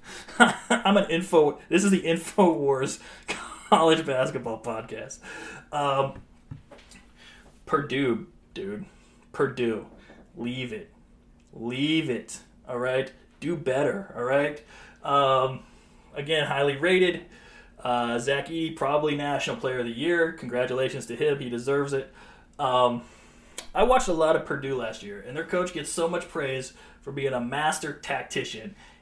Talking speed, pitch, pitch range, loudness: 135 wpm, 140 Hz, 125-165 Hz, -26 LUFS